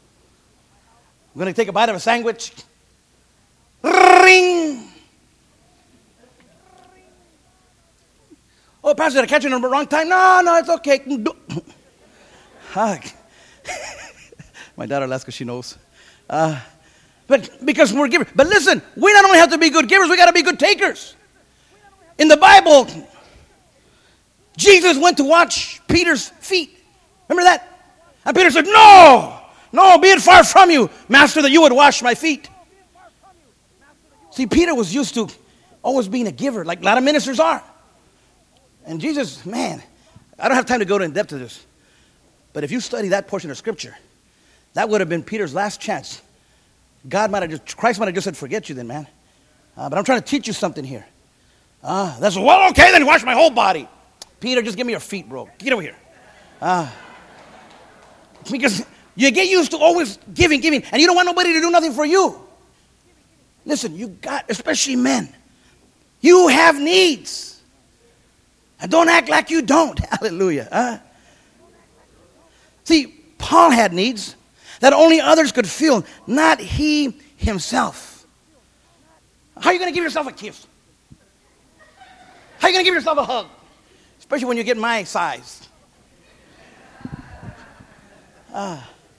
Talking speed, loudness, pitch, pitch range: 155 wpm, -14 LUFS, 280 Hz, 215-335 Hz